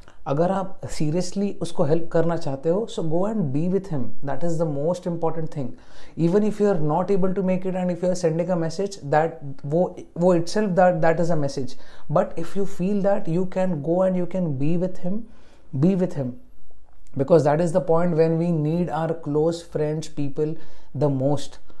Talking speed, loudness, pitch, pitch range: 210 wpm, -23 LUFS, 170 Hz, 150-185 Hz